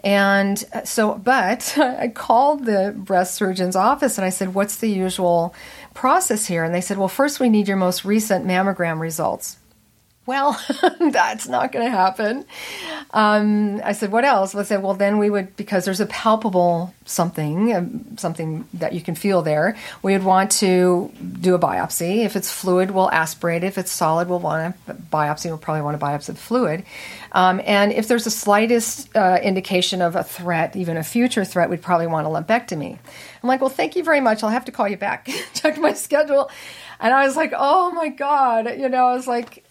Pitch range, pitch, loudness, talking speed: 180-240 Hz, 200 Hz, -20 LUFS, 200 wpm